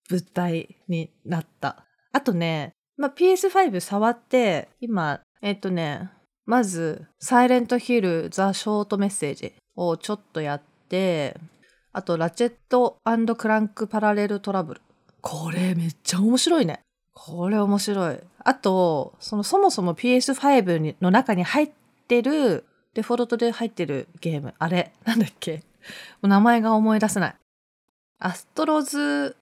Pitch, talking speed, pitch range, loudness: 205 Hz, 270 characters per minute, 175-240 Hz, -23 LUFS